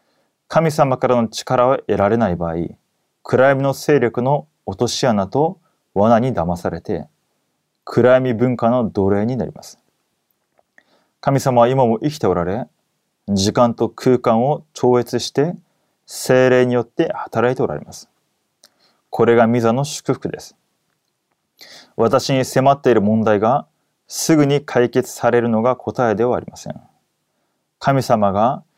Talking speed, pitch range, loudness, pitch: 250 characters per minute, 115-135 Hz, -17 LUFS, 125 Hz